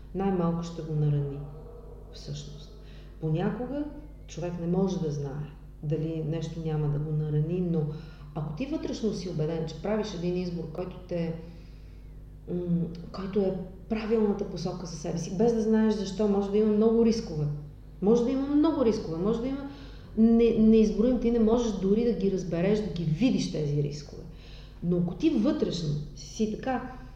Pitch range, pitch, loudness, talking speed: 155-220 Hz, 180 Hz, -28 LUFS, 160 wpm